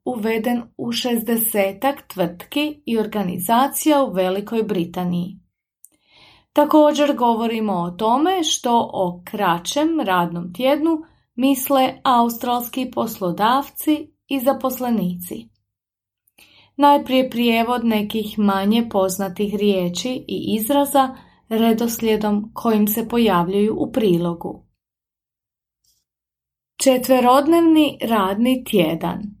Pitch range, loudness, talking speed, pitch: 185-260 Hz, -19 LUFS, 80 wpm, 225 Hz